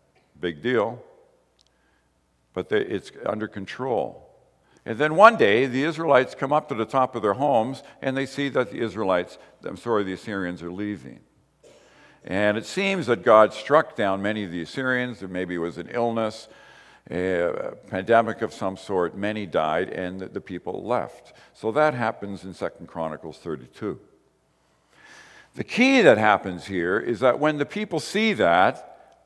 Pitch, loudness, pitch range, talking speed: 110 Hz, -23 LUFS, 95-135 Hz, 160 wpm